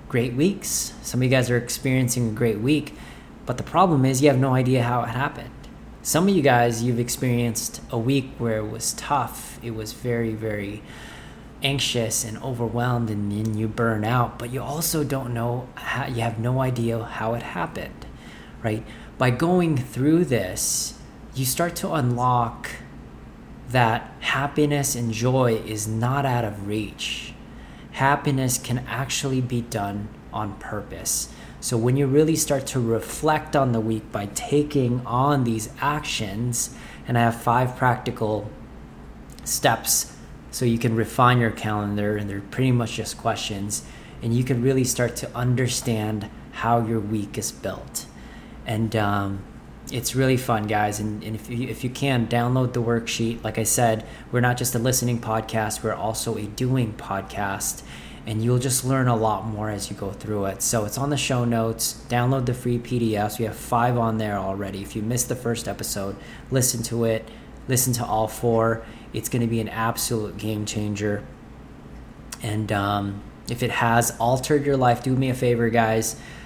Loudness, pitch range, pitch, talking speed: -24 LUFS, 110-130 Hz, 120 Hz, 170 wpm